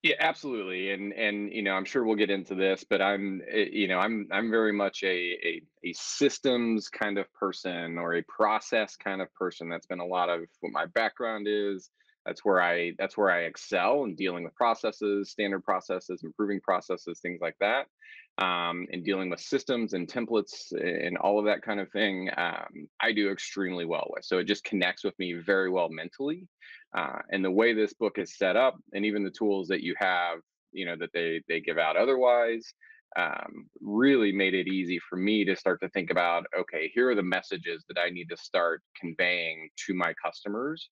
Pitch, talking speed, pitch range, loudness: 100 Hz, 205 wpm, 90-105 Hz, -29 LUFS